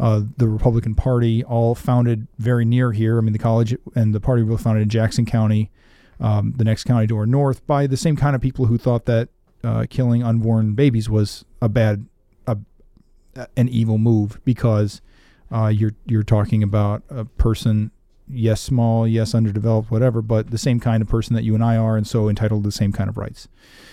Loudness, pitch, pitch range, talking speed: -19 LUFS, 115 Hz, 110-120 Hz, 200 wpm